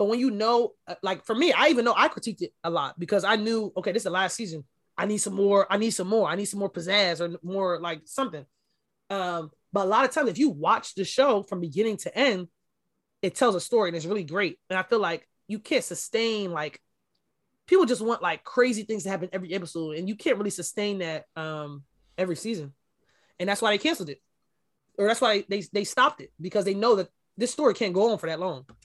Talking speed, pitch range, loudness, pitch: 240 wpm, 175-220 Hz, -26 LUFS, 200 Hz